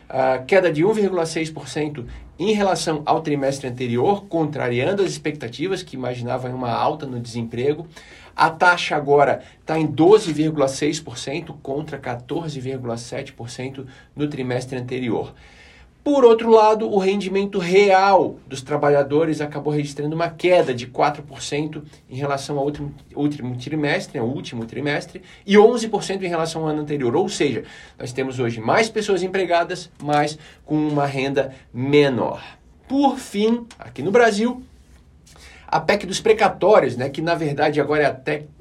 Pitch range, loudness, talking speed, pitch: 135-180 Hz, -20 LUFS, 130 wpm, 150 Hz